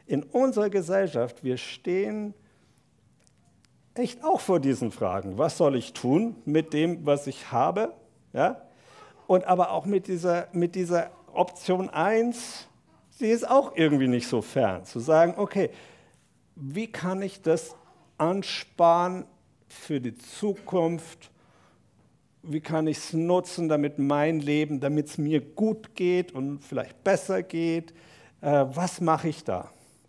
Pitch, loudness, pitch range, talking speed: 165 Hz, -27 LUFS, 145-190 Hz, 135 wpm